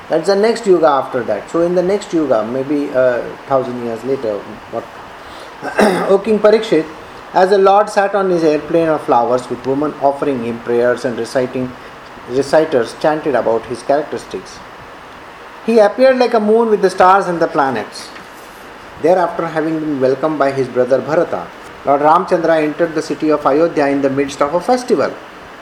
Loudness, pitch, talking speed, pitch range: -14 LUFS, 155 Hz, 175 wpm, 135-180 Hz